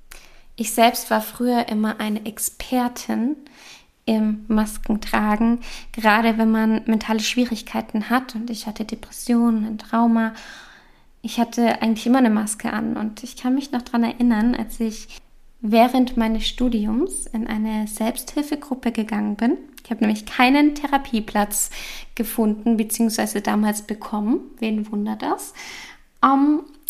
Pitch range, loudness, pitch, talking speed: 220-250 Hz, -21 LUFS, 230 Hz, 130 wpm